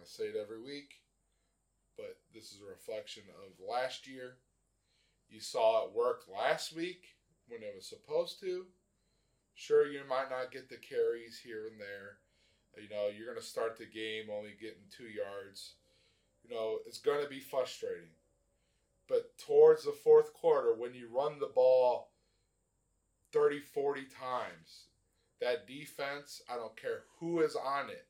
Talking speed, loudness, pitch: 160 wpm, -35 LUFS, 140 Hz